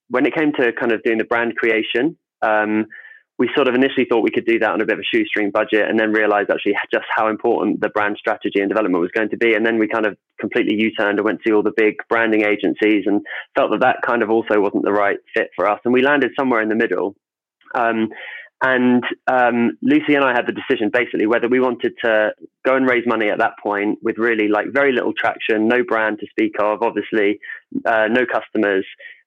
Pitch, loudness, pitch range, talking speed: 115 Hz, -18 LUFS, 110-125 Hz, 235 wpm